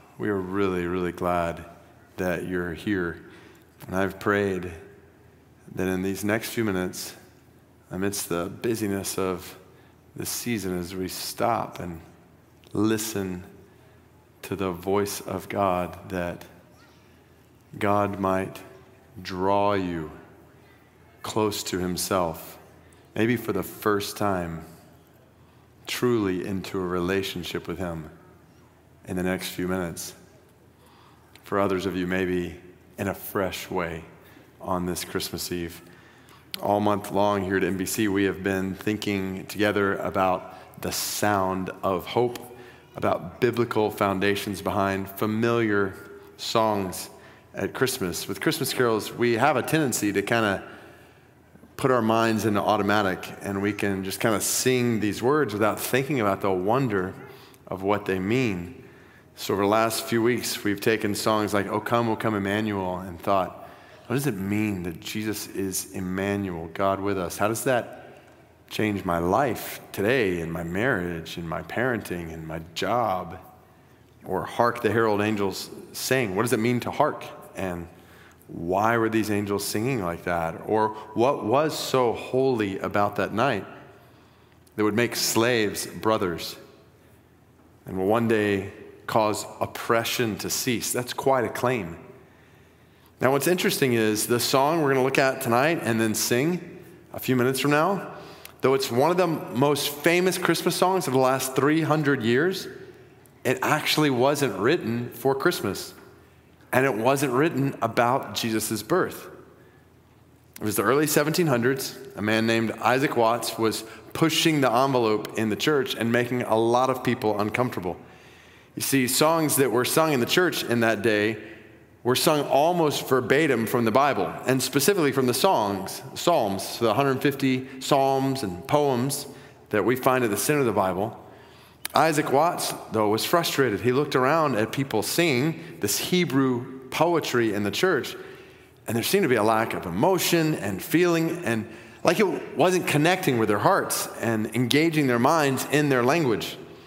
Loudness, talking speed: -25 LUFS, 150 wpm